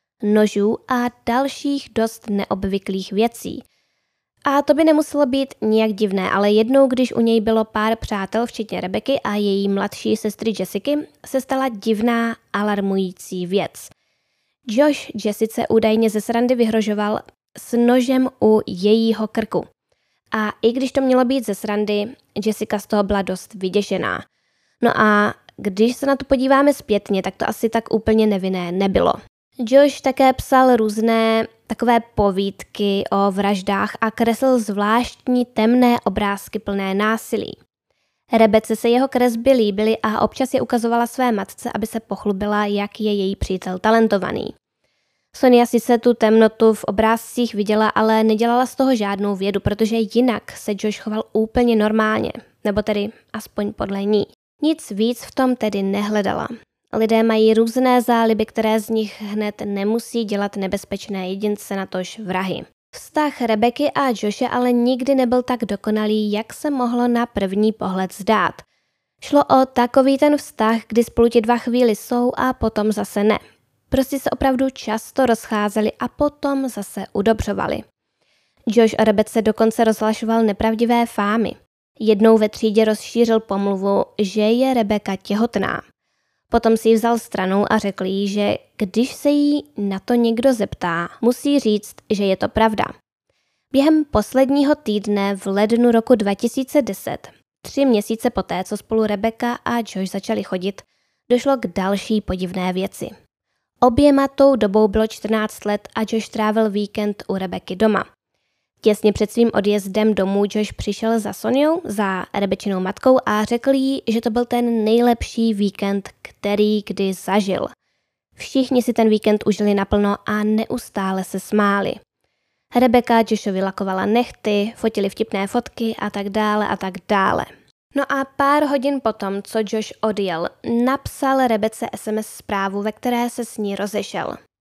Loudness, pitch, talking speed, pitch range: -19 LUFS, 220 Hz, 150 wpm, 205-240 Hz